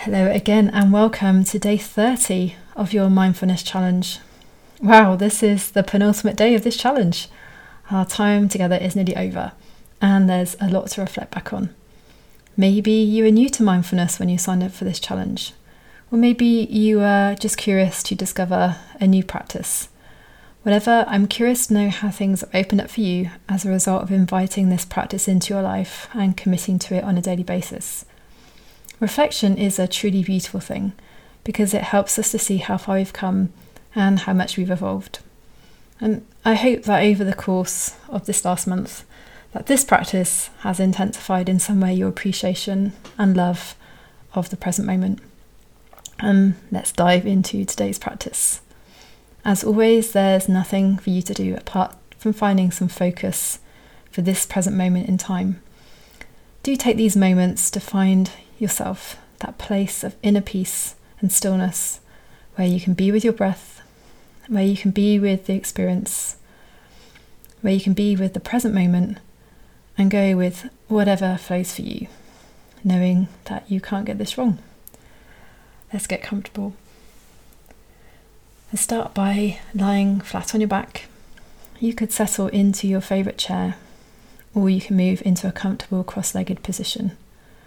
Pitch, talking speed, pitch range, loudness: 195 Hz, 165 wpm, 185-205 Hz, -20 LUFS